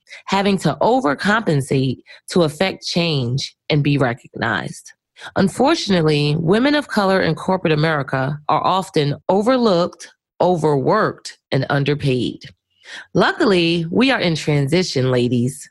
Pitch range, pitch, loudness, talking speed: 145-190 Hz, 160 Hz, -18 LUFS, 105 wpm